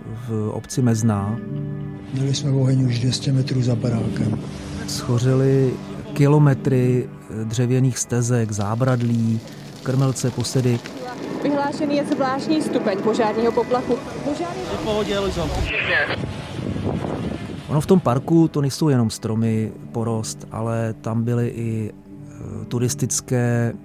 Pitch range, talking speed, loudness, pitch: 115-150 Hz, 100 wpm, -21 LUFS, 125 Hz